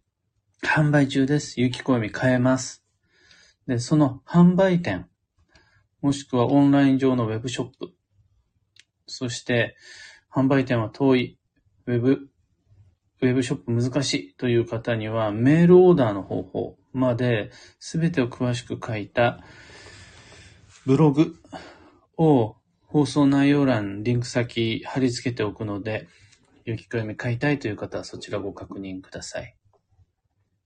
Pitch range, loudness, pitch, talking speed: 100-135 Hz, -23 LUFS, 120 Hz, 260 characters per minute